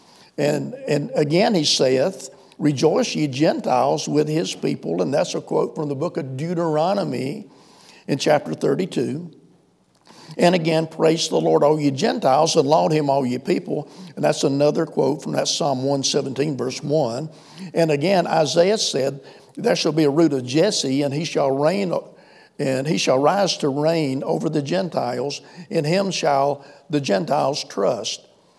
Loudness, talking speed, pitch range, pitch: -20 LUFS, 160 wpm, 140-165 Hz, 155 Hz